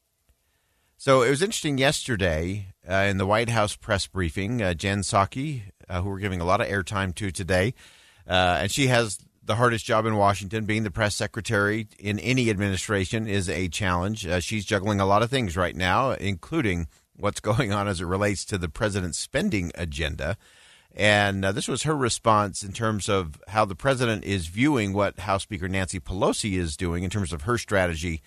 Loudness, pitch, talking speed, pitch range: -25 LUFS, 100 Hz, 195 wpm, 90-110 Hz